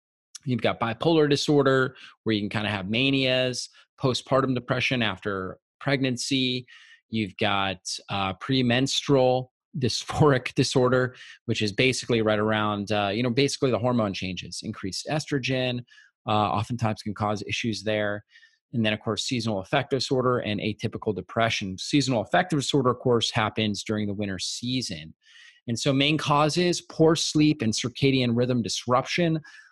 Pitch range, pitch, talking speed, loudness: 105-135 Hz, 120 Hz, 145 wpm, -25 LUFS